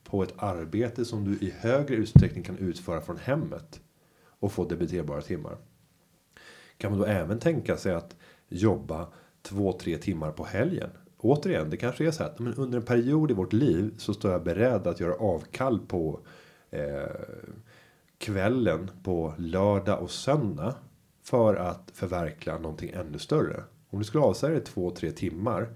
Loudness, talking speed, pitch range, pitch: -29 LUFS, 160 wpm, 90-120 Hz, 100 Hz